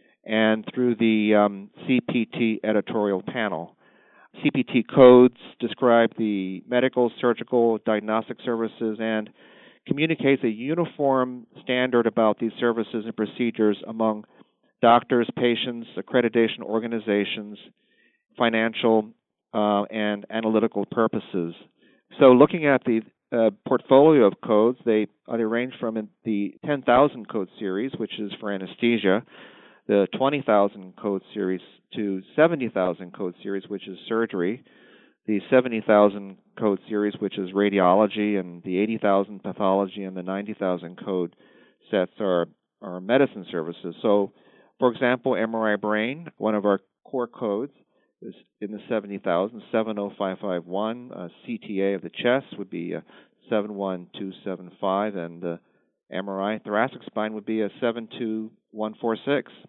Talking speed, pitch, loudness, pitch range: 120 wpm, 110 Hz, -24 LUFS, 100-115 Hz